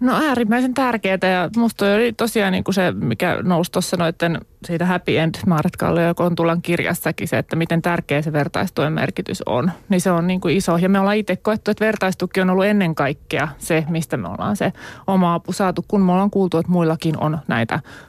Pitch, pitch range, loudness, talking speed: 180 Hz, 165-195 Hz, -19 LUFS, 200 wpm